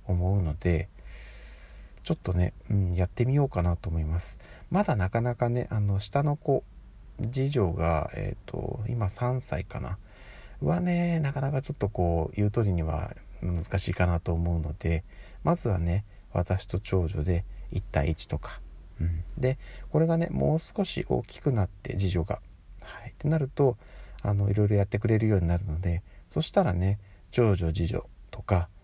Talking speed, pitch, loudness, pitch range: 310 characters per minute, 100 Hz, -29 LUFS, 85-125 Hz